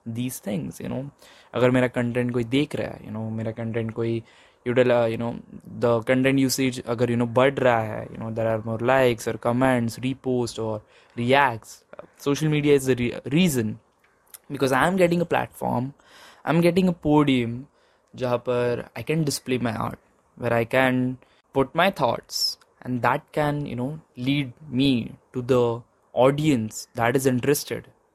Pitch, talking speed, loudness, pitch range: 125 Hz, 165 wpm, -24 LUFS, 115-140 Hz